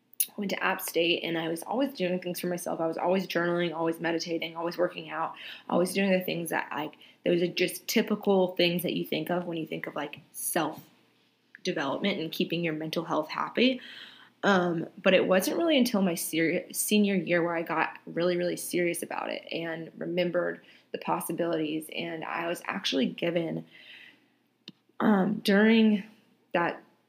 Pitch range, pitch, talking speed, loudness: 165-200 Hz, 175 Hz, 175 wpm, -29 LUFS